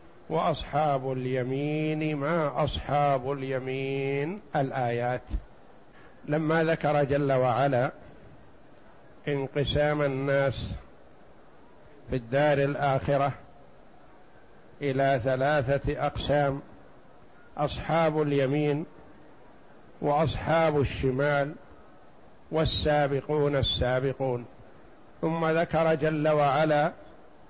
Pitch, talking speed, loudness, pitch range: 140 Hz, 60 wpm, -27 LUFS, 135-150 Hz